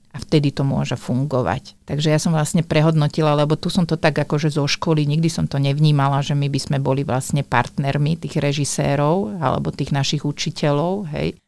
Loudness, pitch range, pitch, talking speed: -20 LUFS, 140-155 Hz, 150 Hz, 190 wpm